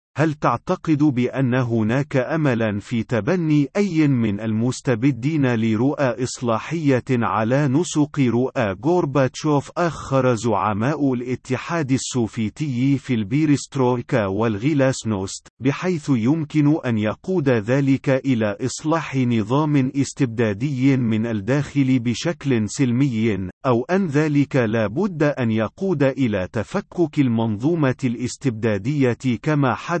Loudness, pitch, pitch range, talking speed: -21 LUFS, 130 Hz, 115-145 Hz, 100 wpm